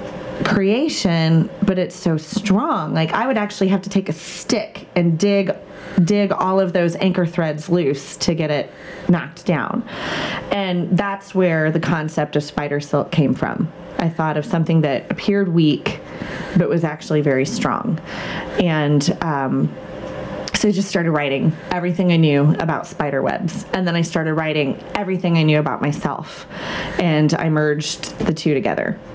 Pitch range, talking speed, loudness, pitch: 155-195 Hz, 165 wpm, -19 LUFS, 175 Hz